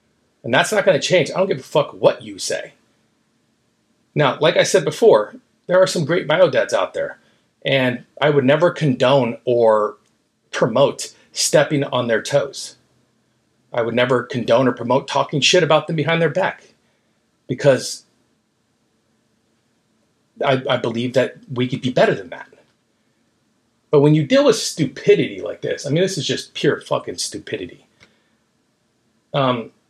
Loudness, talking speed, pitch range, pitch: -18 LUFS, 155 wpm, 115-160 Hz, 130 Hz